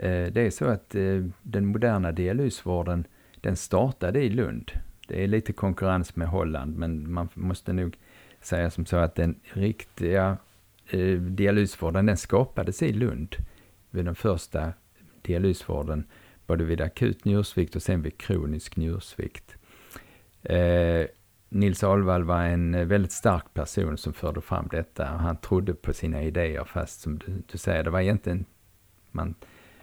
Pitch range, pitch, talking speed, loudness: 85-100 Hz, 90 Hz, 140 wpm, -27 LUFS